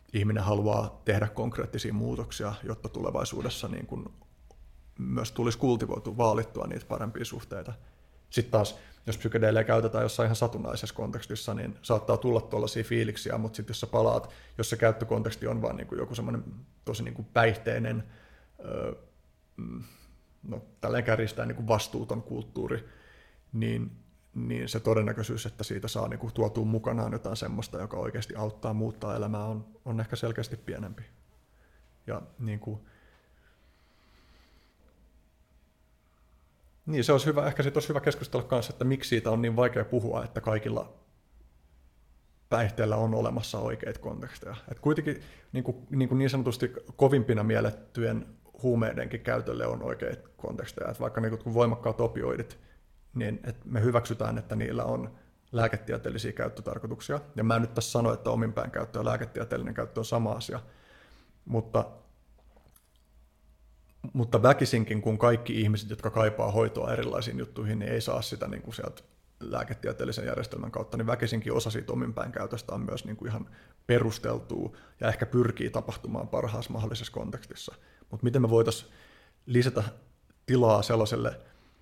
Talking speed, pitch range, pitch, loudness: 135 wpm, 105-115 Hz, 110 Hz, -30 LUFS